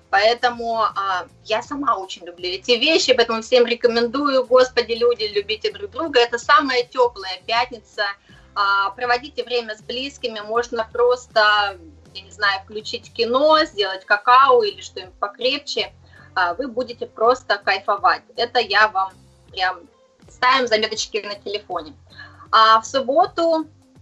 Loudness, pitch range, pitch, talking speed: -19 LUFS, 210-260 Hz, 240 Hz, 125 wpm